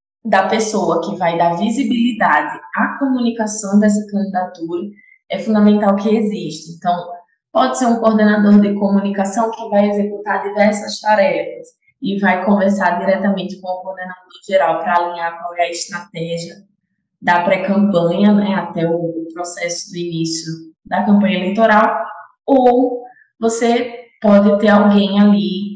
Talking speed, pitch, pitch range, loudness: 135 wpm, 200 Hz, 175-215 Hz, -16 LUFS